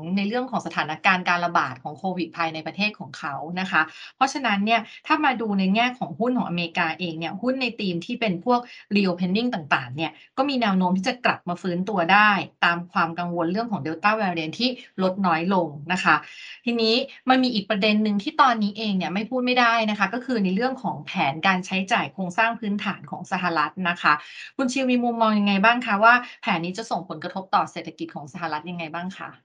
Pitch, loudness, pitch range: 195 Hz, -23 LUFS, 175-230 Hz